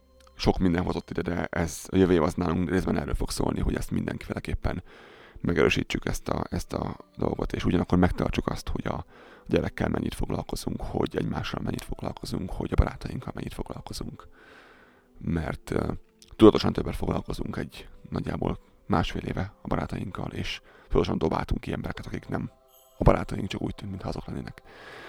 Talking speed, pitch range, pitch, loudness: 165 wpm, 85-130 Hz, 95 Hz, -29 LUFS